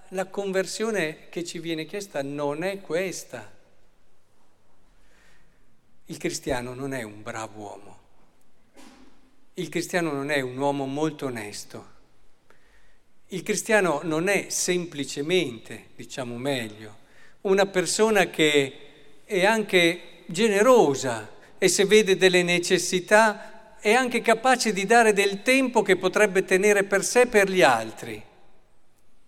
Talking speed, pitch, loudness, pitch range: 115 wpm, 180 Hz, -23 LUFS, 140-205 Hz